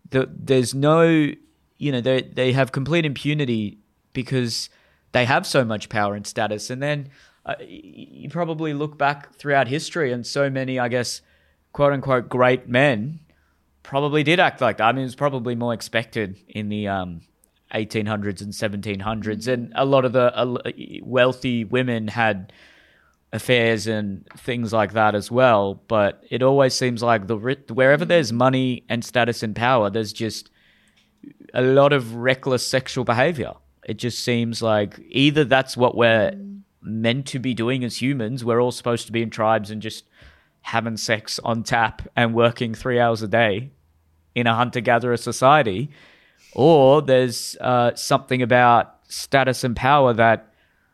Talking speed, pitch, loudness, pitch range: 160 wpm, 120 Hz, -20 LUFS, 110-135 Hz